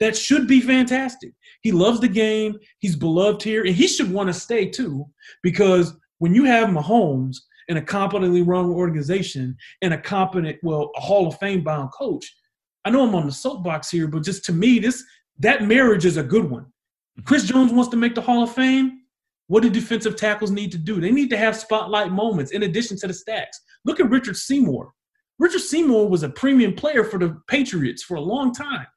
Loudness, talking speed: -20 LUFS, 205 wpm